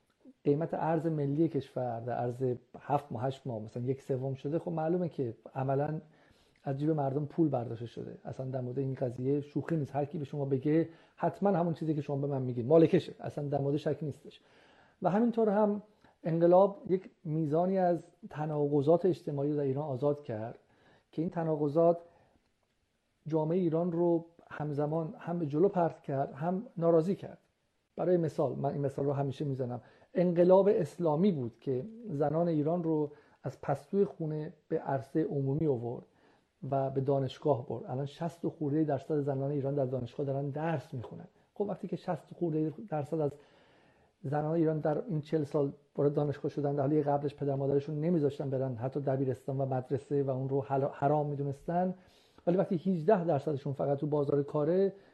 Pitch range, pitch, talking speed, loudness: 140-165 Hz, 150 Hz, 170 wpm, -32 LUFS